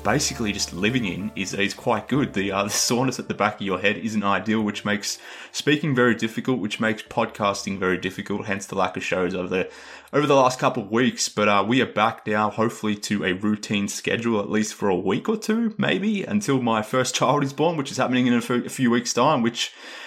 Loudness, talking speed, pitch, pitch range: -23 LUFS, 235 wpm, 110 Hz, 100-130 Hz